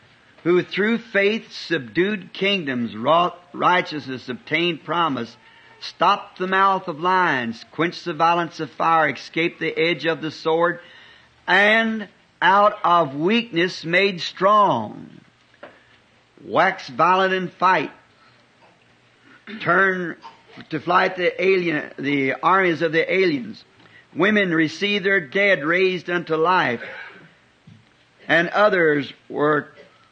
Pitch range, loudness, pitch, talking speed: 155-195 Hz, -20 LUFS, 175 Hz, 110 wpm